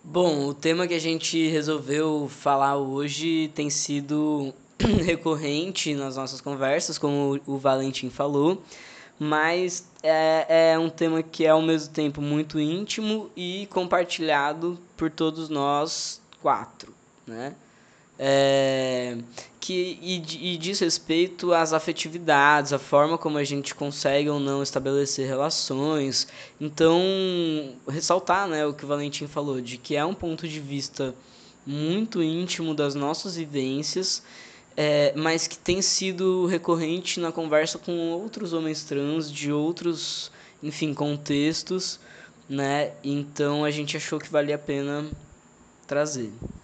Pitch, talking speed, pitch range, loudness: 155 Hz, 130 wpm, 140-170 Hz, -25 LUFS